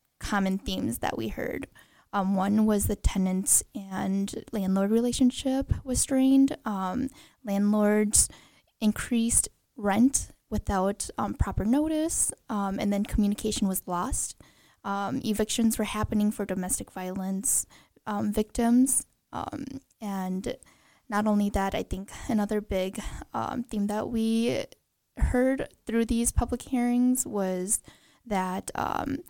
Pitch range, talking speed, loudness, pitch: 200-245 Hz, 120 wpm, -27 LUFS, 215 Hz